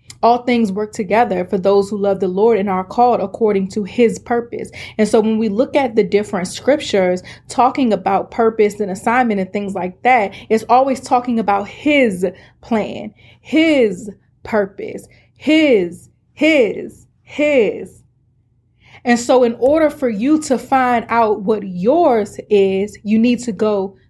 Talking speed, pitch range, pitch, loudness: 155 wpm, 200-250 Hz, 220 Hz, -16 LUFS